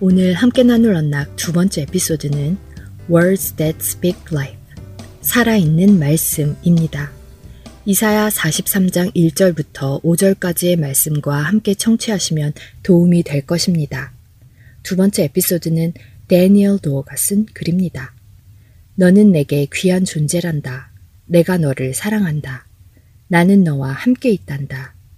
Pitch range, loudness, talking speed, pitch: 135-185 Hz, -15 LUFS, 295 characters per minute, 165 Hz